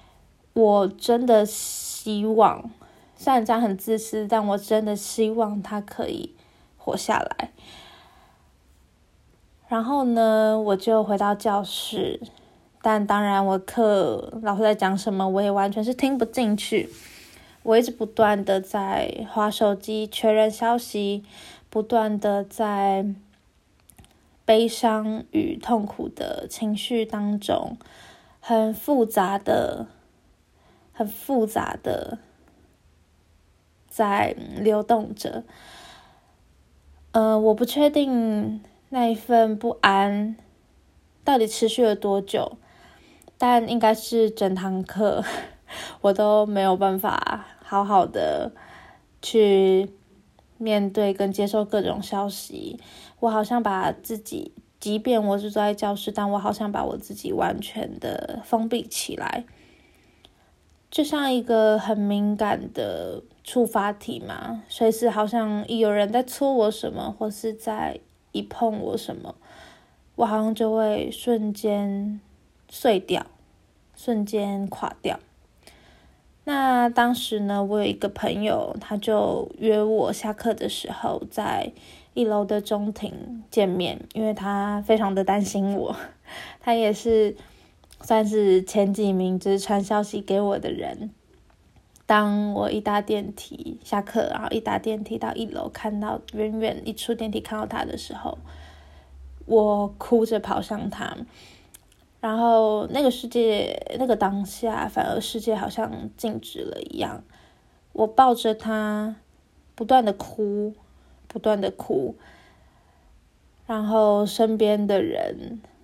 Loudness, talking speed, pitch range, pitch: -24 LUFS, 175 characters per minute, 205-225 Hz, 215 Hz